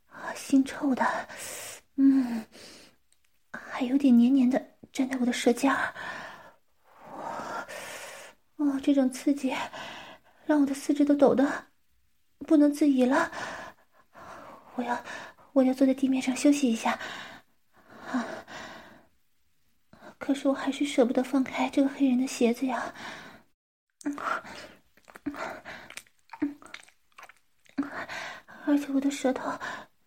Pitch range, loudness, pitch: 260-300 Hz, -27 LUFS, 275 Hz